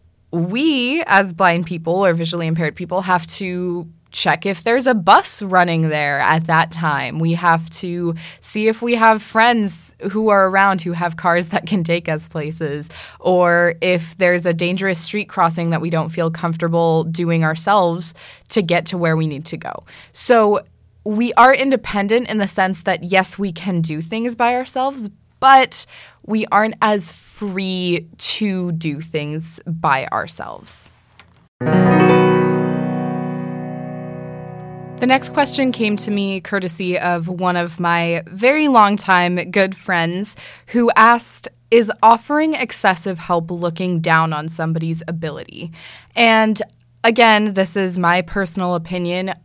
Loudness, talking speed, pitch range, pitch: -17 LUFS, 145 wpm, 165-205 Hz, 180 Hz